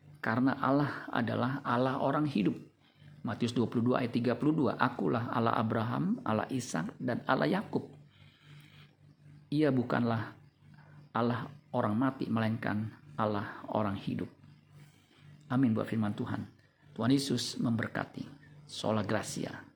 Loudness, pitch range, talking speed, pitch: -32 LUFS, 115-145 Hz, 110 wpm, 130 Hz